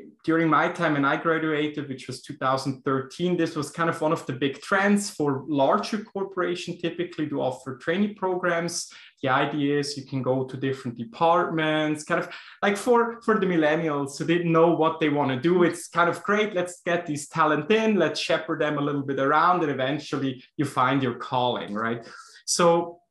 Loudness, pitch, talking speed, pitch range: -25 LUFS, 155 Hz, 195 wpm, 140-175 Hz